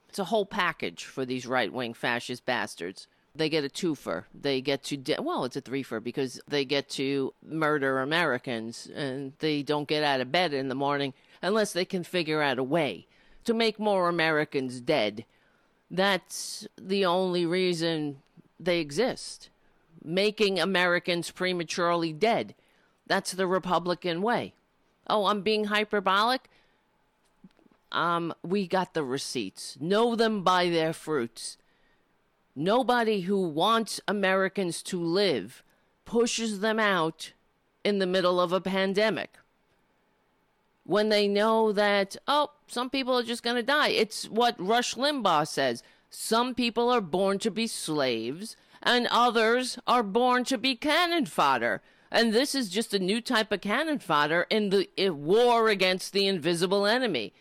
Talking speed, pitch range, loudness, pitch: 150 wpm, 155-220 Hz, -27 LUFS, 190 Hz